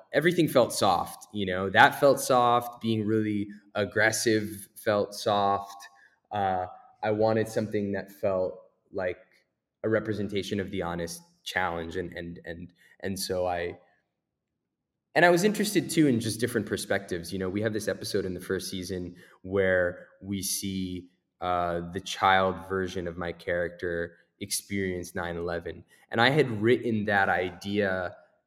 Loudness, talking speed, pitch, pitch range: -28 LUFS, 145 wpm, 95 Hz, 90-110 Hz